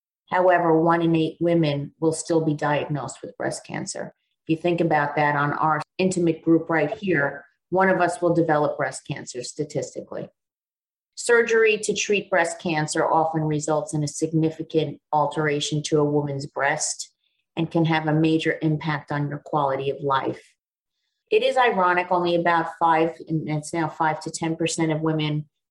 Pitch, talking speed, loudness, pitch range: 160 Hz, 165 wpm, -23 LUFS, 150-170 Hz